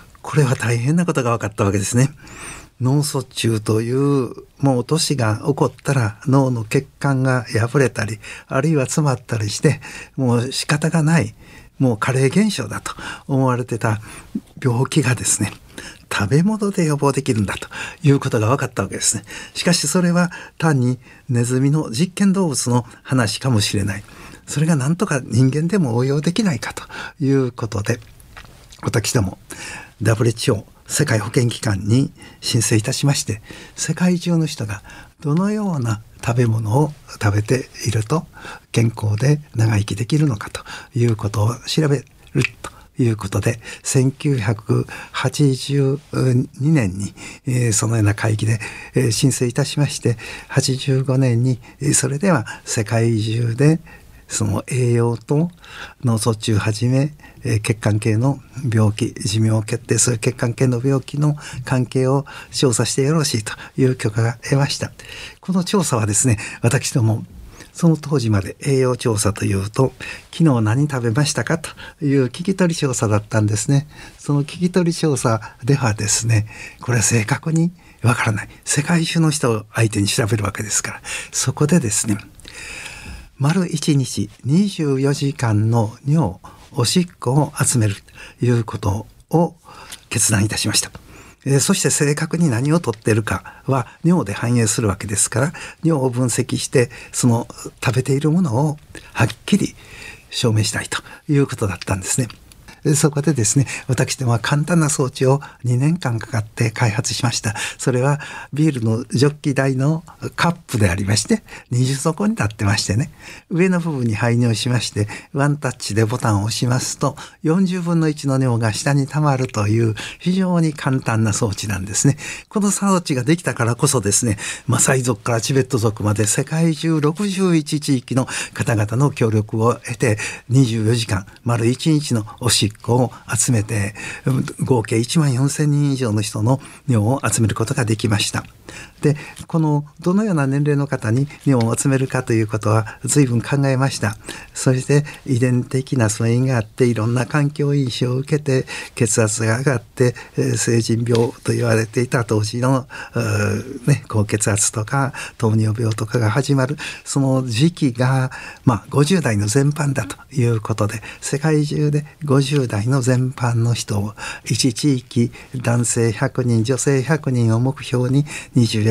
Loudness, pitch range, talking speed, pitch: -19 LUFS, 115-145 Hz, 295 characters per minute, 130 Hz